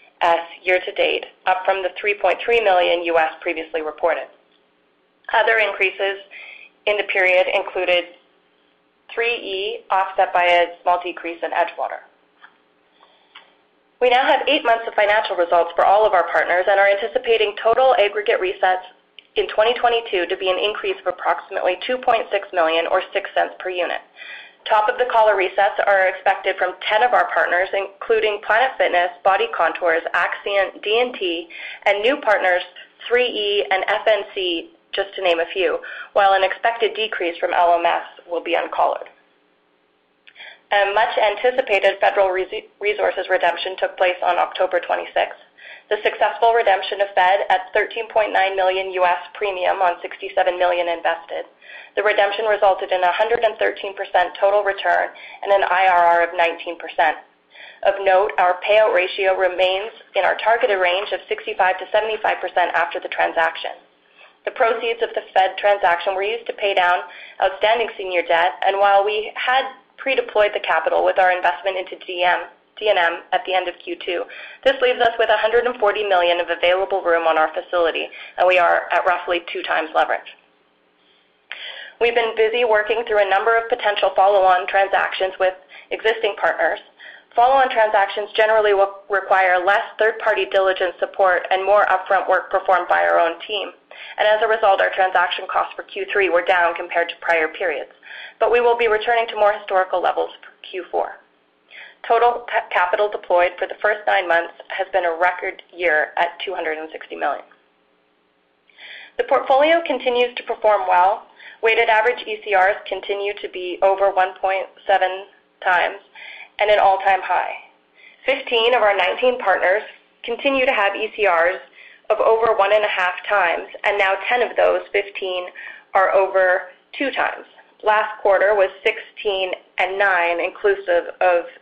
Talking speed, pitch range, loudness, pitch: 155 wpm, 180-215 Hz, -19 LUFS, 190 Hz